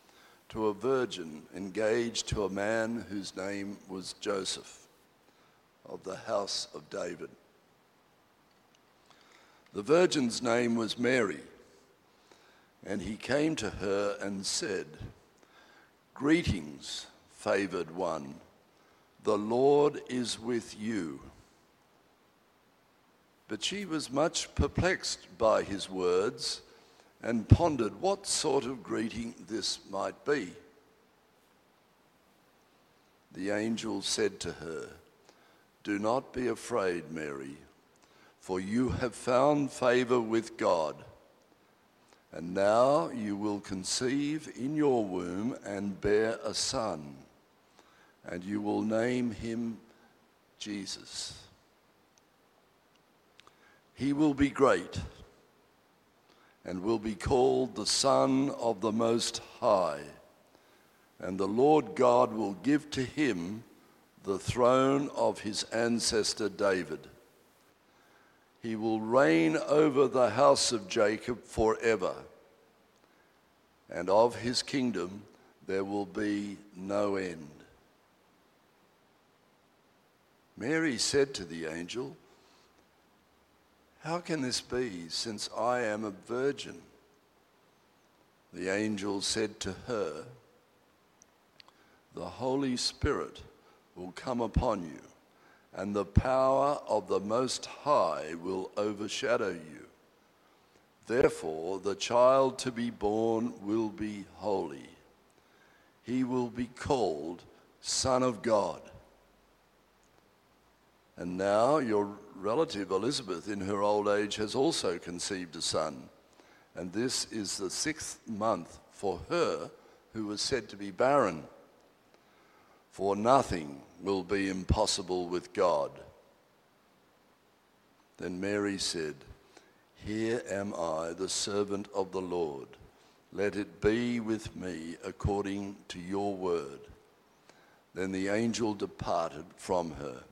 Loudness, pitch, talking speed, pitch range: -31 LUFS, 110 Hz, 105 wpm, 100-125 Hz